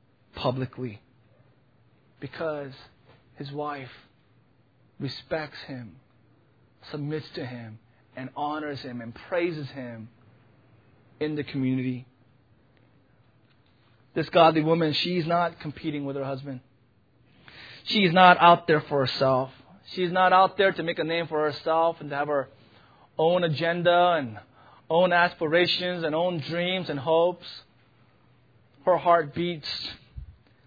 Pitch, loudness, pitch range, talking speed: 140 Hz, -25 LUFS, 125-165 Hz, 115 wpm